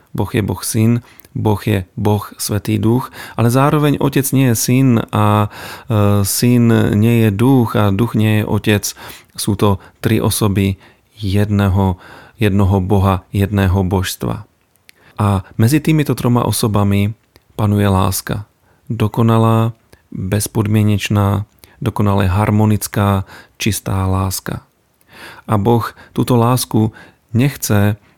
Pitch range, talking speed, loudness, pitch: 100-115 Hz, 110 wpm, -15 LUFS, 105 Hz